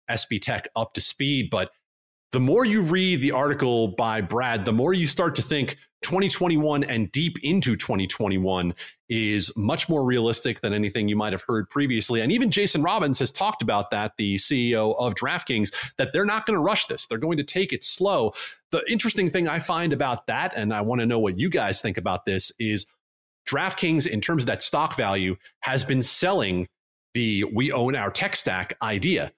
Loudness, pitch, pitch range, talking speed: -24 LUFS, 125 Hz, 105-155 Hz, 200 wpm